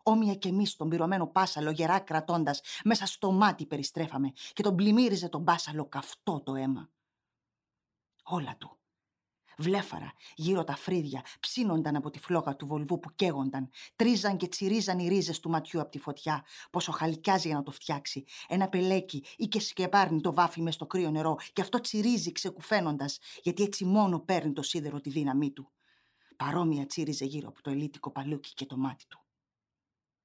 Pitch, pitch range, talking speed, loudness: 165 Hz, 150-190 Hz, 170 wpm, -31 LUFS